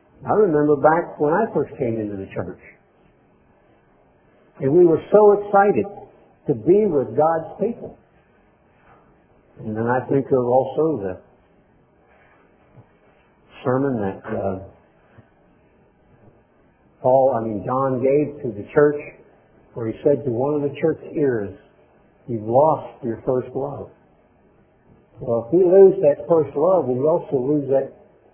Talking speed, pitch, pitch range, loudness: 135 wpm, 135 Hz, 120-155 Hz, -20 LUFS